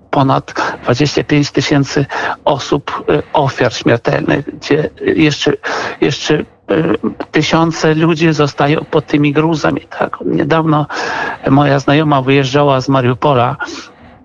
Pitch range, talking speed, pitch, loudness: 140-155 Hz, 95 wpm, 150 Hz, -13 LUFS